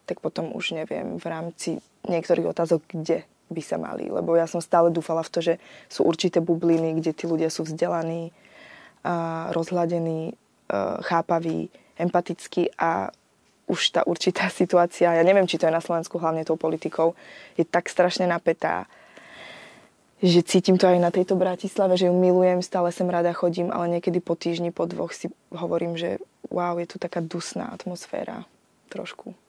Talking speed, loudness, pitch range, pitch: 165 wpm, -24 LUFS, 165-180 Hz, 170 Hz